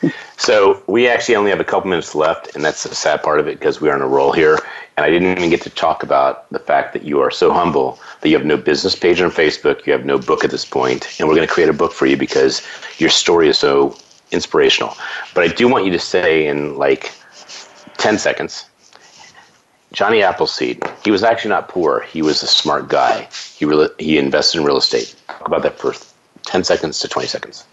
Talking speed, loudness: 230 wpm, -15 LUFS